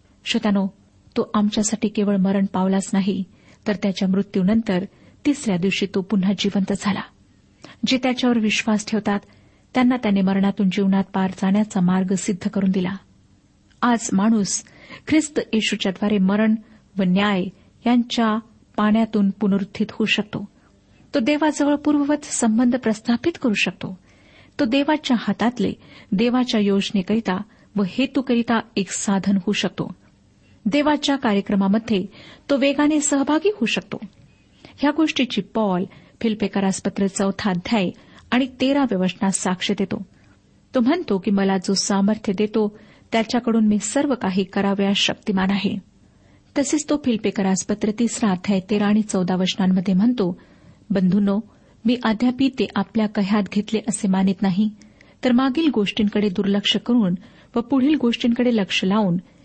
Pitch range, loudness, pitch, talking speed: 195-235 Hz, -21 LUFS, 210 Hz, 120 wpm